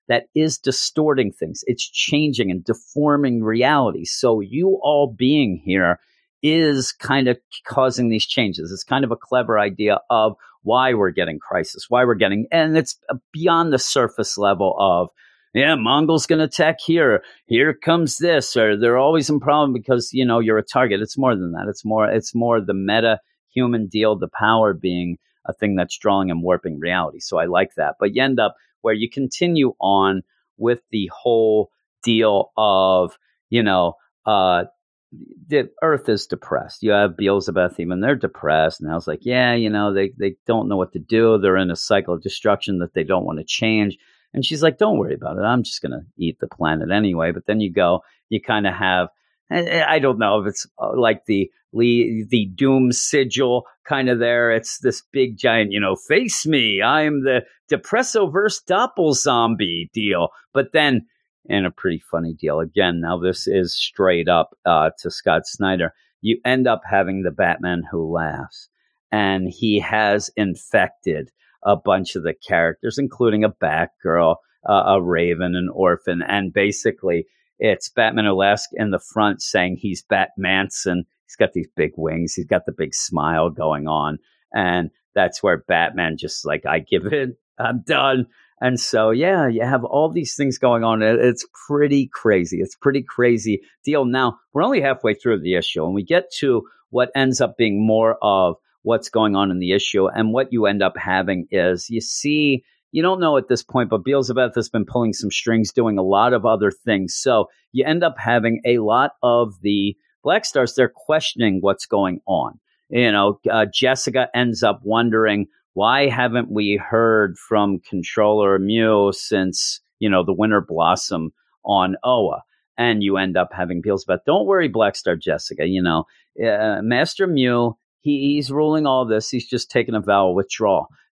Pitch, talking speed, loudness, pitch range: 110 Hz, 185 wpm, -19 LUFS, 95-130 Hz